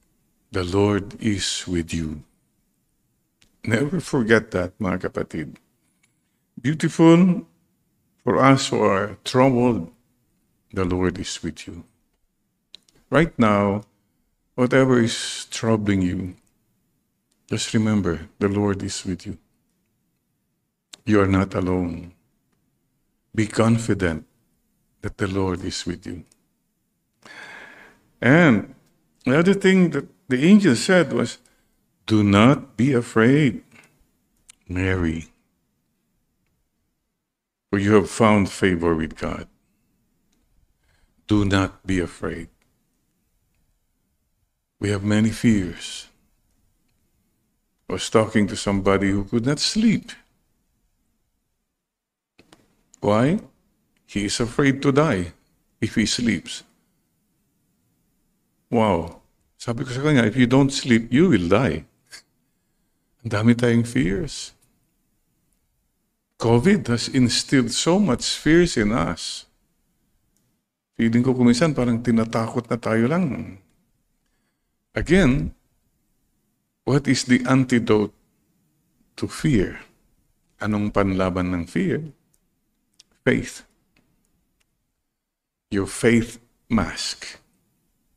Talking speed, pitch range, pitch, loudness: 95 wpm, 95-125 Hz, 110 Hz, -21 LUFS